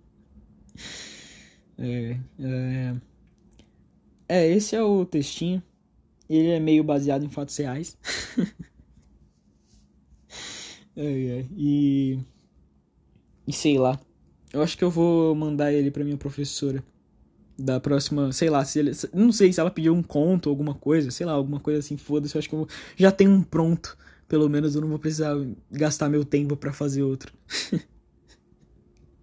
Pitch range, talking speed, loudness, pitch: 130-155 Hz, 150 wpm, -24 LUFS, 145 Hz